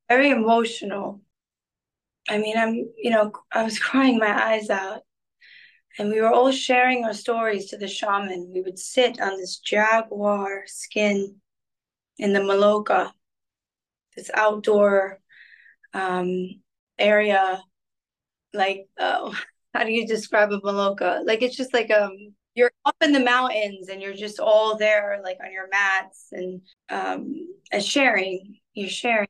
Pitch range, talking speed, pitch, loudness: 195-230 Hz, 145 wpm, 210 Hz, -22 LUFS